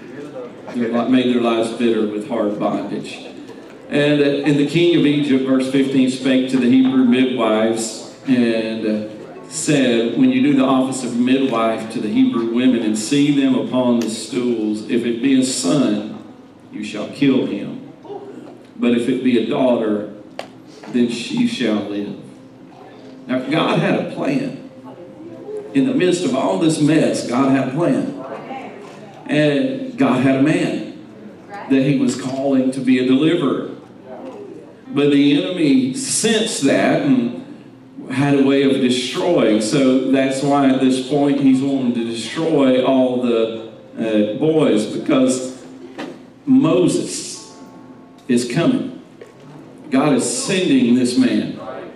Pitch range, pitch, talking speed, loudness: 120-150 Hz, 130 Hz, 140 wpm, -17 LUFS